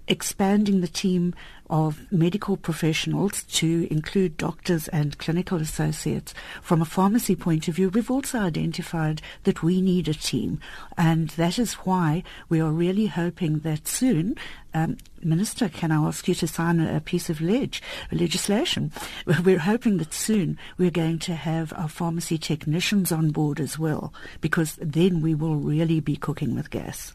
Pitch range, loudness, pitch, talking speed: 160-185 Hz, -25 LUFS, 170 Hz, 160 wpm